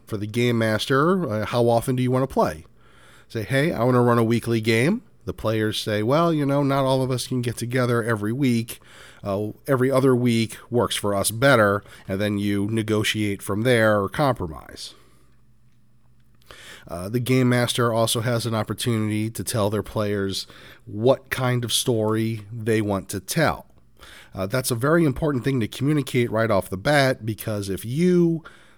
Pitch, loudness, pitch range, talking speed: 115 Hz, -22 LUFS, 105-130 Hz, 180 wpm